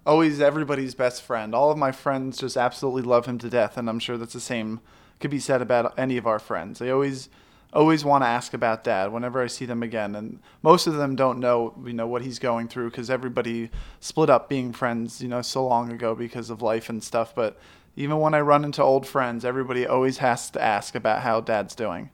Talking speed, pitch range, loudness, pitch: 235 wpm, 115-135 Hz, -24 LUFS, 125 Hz